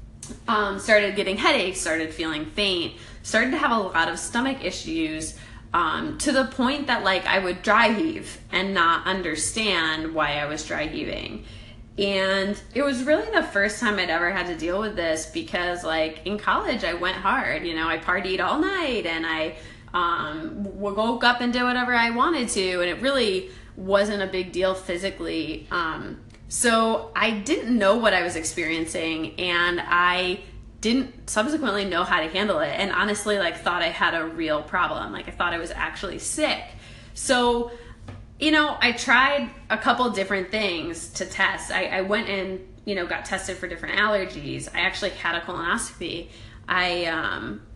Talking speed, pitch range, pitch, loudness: 180 wpm, 170-235 Hz, 190 Hz, -24 LUFS